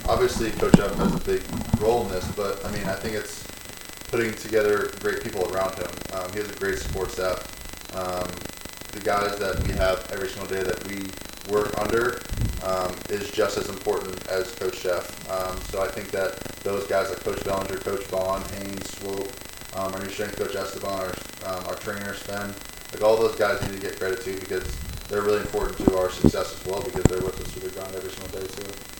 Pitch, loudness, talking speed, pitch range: 100 Hz, -27 LUFS, 215 wpm, 95-105 Hz